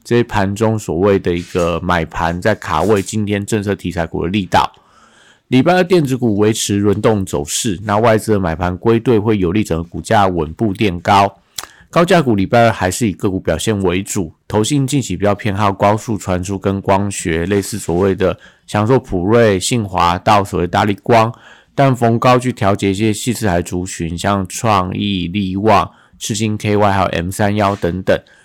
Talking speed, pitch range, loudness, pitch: 280 characters per minute, 90-110 Hz, -15 LUFS, 100 Hz